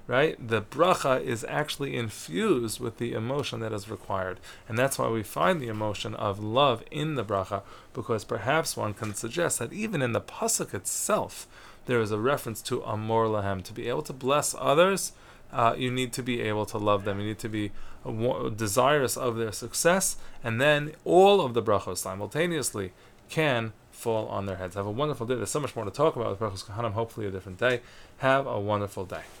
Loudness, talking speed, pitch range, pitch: -28 LUFS, 200 wpm, 105-130 Hz, 115 Hz